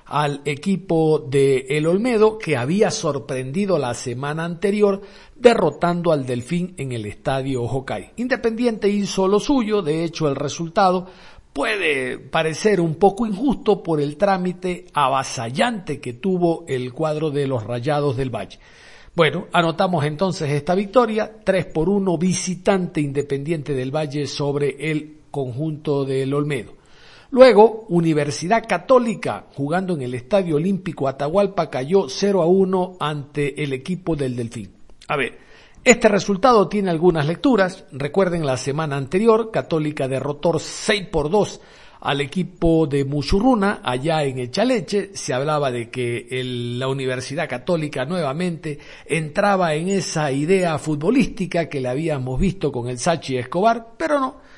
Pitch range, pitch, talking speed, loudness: 140-195 Hz, 165 Hz, 140 wpm, -20 LUFS